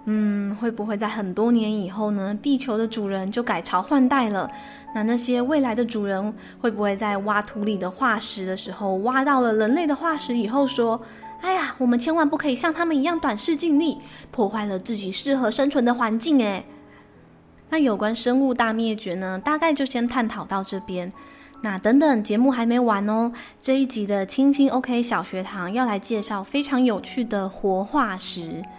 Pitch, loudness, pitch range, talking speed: 230 Hz, -23 LUFS, 205-270 Hz, 280 characters per minute